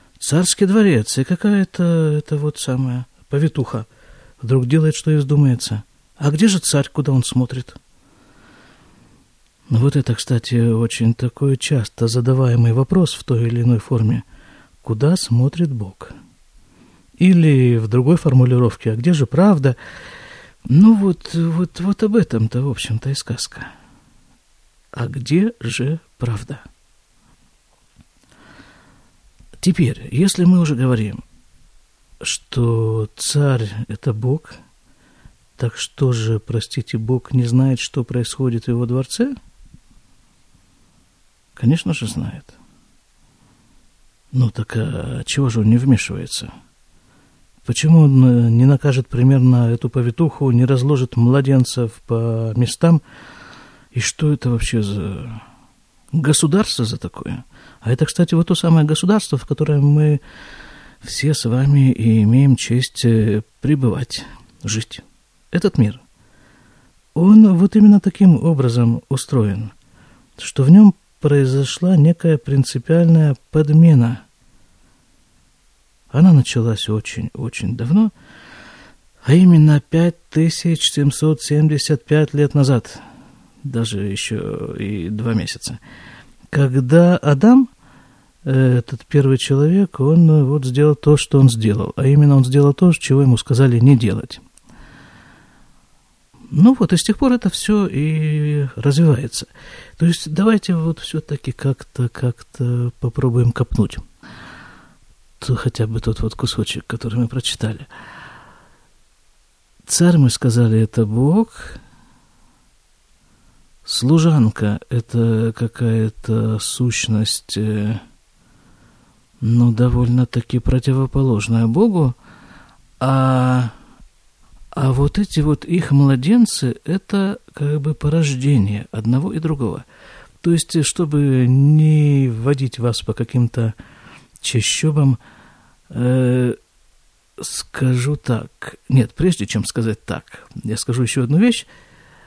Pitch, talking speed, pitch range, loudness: 130 Hz, 110 wpm, 115-155 Hz, -16 LUFS